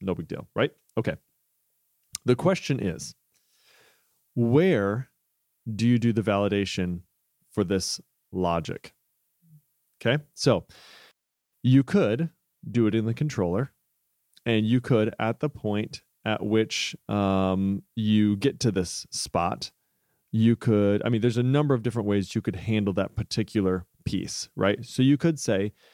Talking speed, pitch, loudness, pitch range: 140 wpm, 110 Hz, -26 LUFS, 100-130 Hz